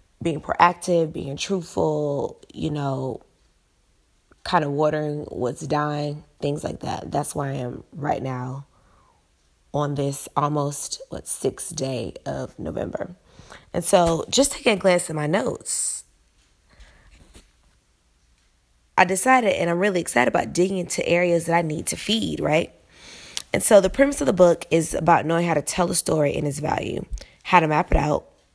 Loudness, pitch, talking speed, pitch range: -22 LUFS, 150 Hz, 160 wpm, 130-175 Hz